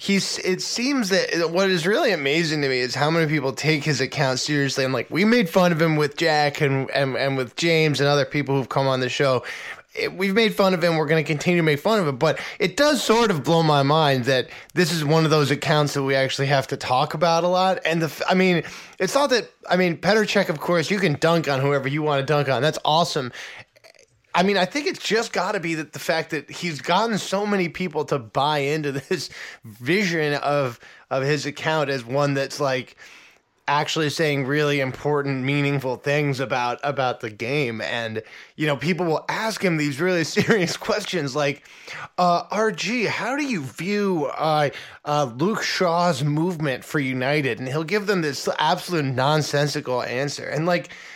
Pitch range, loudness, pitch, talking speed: 140-180 Hz, -22 LUFS, 155 Hz, 210 wpm